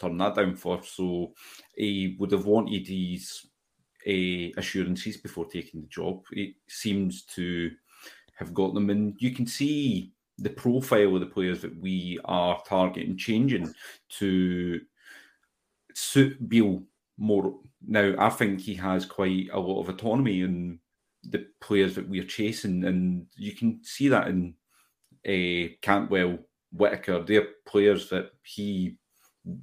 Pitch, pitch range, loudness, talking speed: 95 Hz, 90-105 Hz, -28 LUFS, 140 wpm